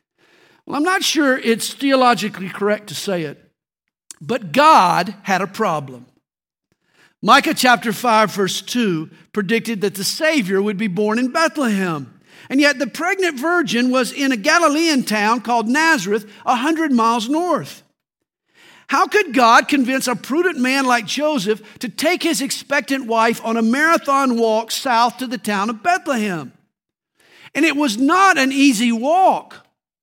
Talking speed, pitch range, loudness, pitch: 150 wpm, 215-290 Hz, -17 LUFS, 245 Hz